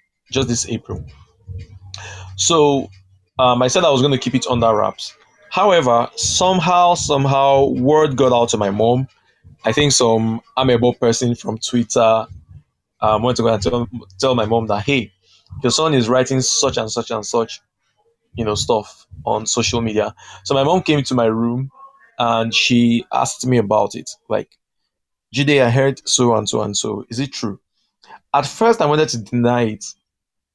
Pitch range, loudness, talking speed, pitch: 110-135 Hz, -17 LUFS, 175 wpm, 120 Hz